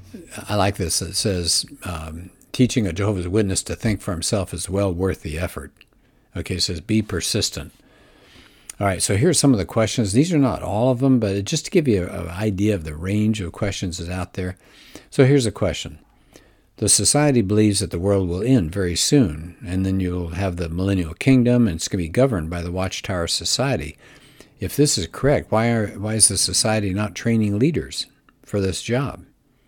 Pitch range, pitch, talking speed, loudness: 90-110 Hz, 100 Hz, 200 wpm, -20 LUFS